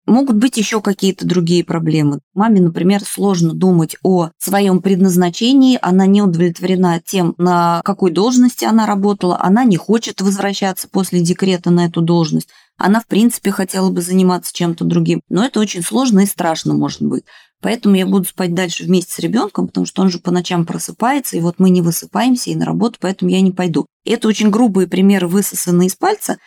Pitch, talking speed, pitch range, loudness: 185 Hz, 185 wpm, 175-205 Hz, -14 LUFS